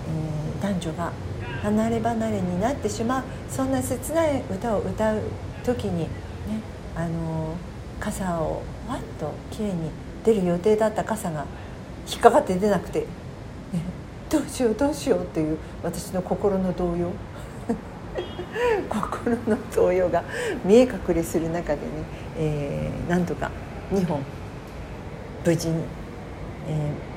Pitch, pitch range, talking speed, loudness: 170 Hz, 140-200 Hz, 230 characters per minute, -26 LUFS